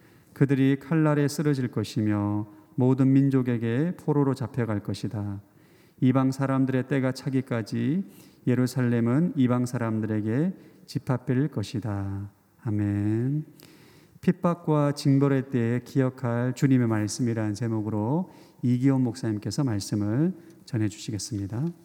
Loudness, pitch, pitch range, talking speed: -26 LUFS, 130 Hz, 110-145 Hz, 275 characters per minute